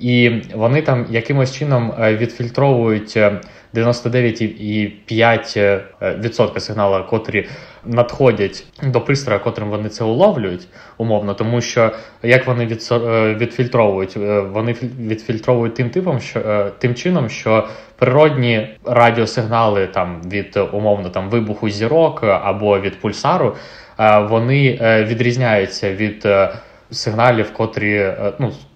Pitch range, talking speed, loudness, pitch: 105-120 Hz, 100 wpm, -16 LUFS, 115 Hz